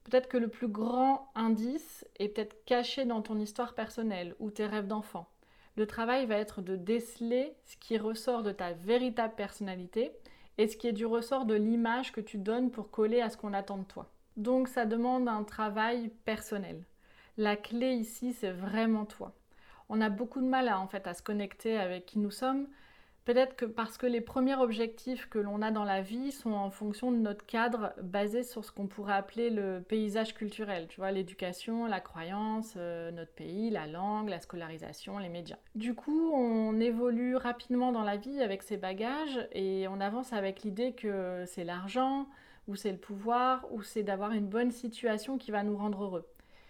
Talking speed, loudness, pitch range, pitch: 195 wpm, -34 LUFS, 205-240 Hz, 220 Hz